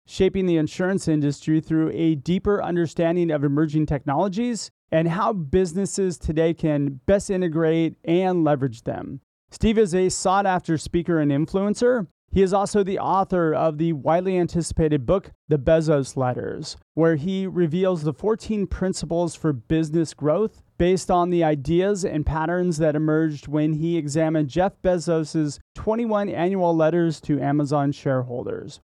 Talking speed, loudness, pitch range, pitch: 145 wpm, -22 LUFS, 155-185 Hz, 165 Hz